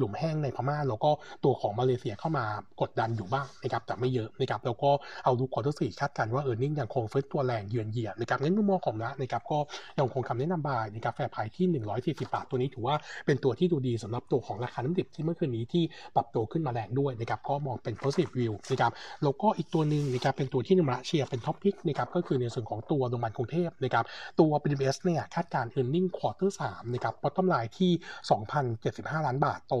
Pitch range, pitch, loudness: 120-155 Hz, 135 Hz, -30 LUFS